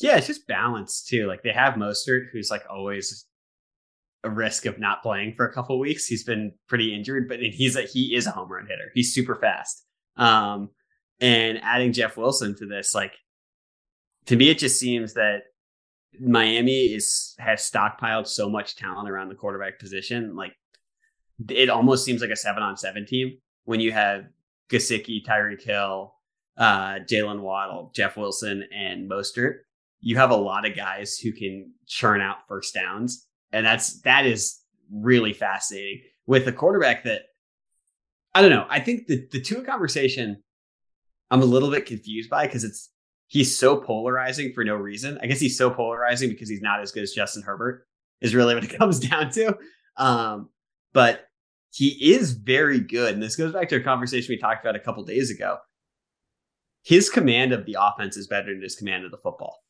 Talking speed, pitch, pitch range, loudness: 190 wpm, 120 Hz, 105-130 Hz, -23 LUFS